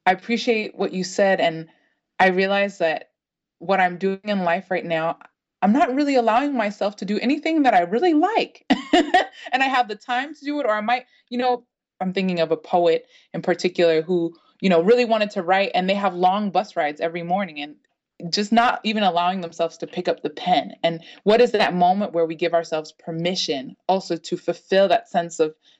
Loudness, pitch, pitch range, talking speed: -21 LUFS, 195 Hz, 170-240 Hz, 210 wpm